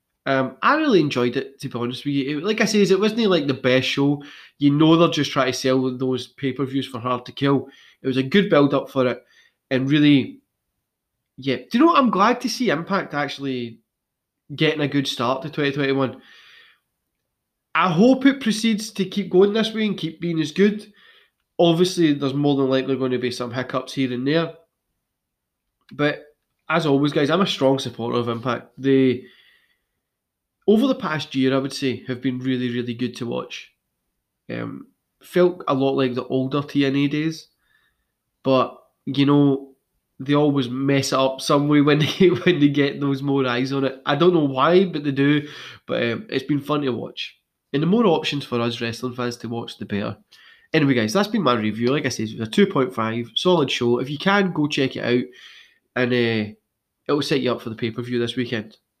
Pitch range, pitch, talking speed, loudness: 125-160 Hz, 140 Hz, 210 wpm, -21 LUFS